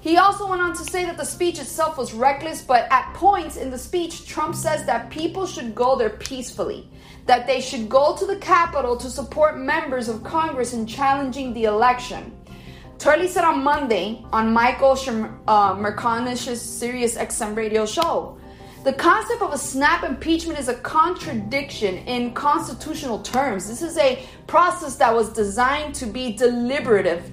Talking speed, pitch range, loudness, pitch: 170 wpm, 240-320 Hz, -21 LUFS, 270 Hz